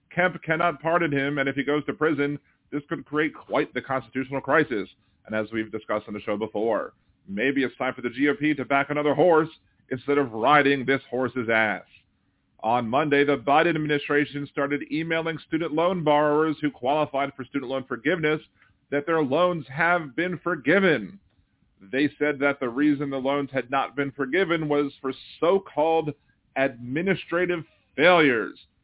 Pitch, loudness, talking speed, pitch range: 145 Hz, -24 LUFS, 165 wpm, 135-155 Hz